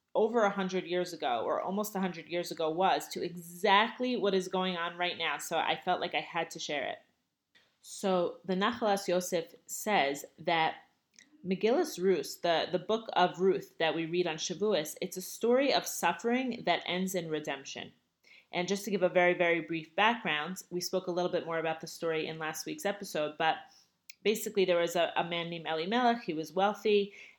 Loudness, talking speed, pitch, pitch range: -32 LUFS, 195 wpm, 180 Hz, 165-200 Hz